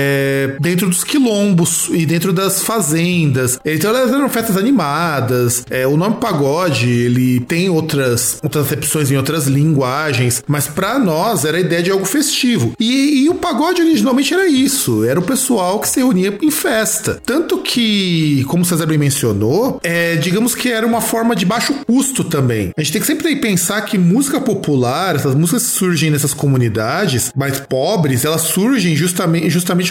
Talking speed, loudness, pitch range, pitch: 175 wpm, -14 LUFS, 145-230 Hz, 175 Hz